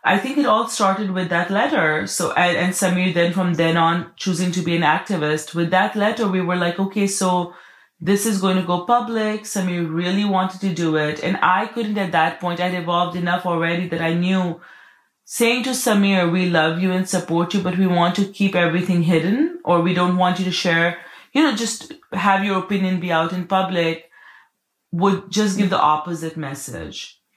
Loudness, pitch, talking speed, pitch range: -19 LUFS, 180 Hz, 200 wpm, 170-200 Hz